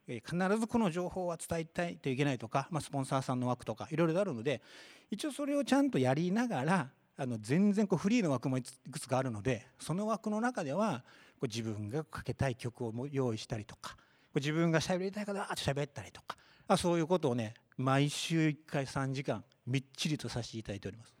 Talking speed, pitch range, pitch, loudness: 415 characters per minute, 125-180 Hz, 140 Hz, -35 LUFS